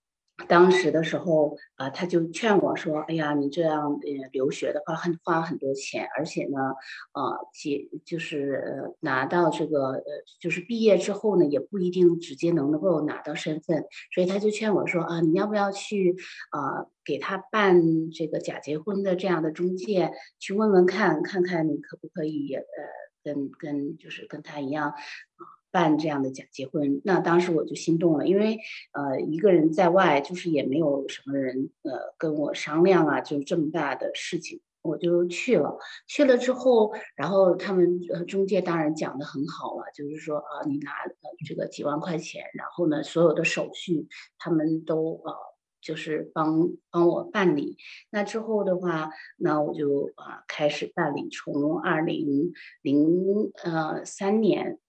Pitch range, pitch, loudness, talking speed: 150-185 Hz, 165 Hz, -26 LUFS, 245 characters per minute